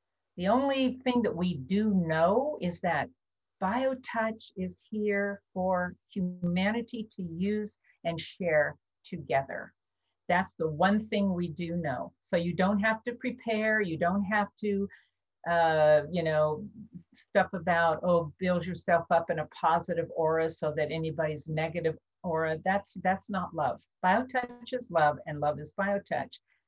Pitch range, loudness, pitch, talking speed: 165-210 Hz, -30 LUFS, 180 Hz, 145 wpm